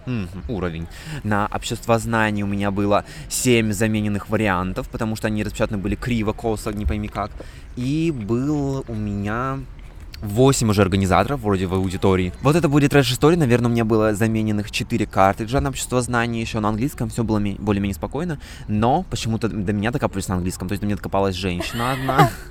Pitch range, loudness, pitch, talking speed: 100-120 Hz, -21 LUFS, 110 Hz, 180 wpm